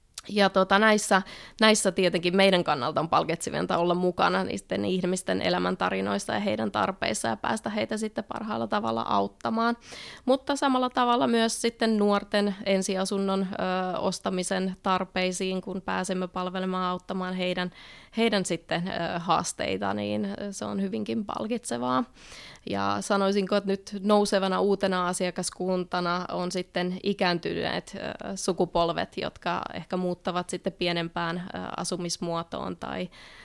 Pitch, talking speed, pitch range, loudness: 185 Hz, 115 wpm, 175-200 Hz, -27 LUFS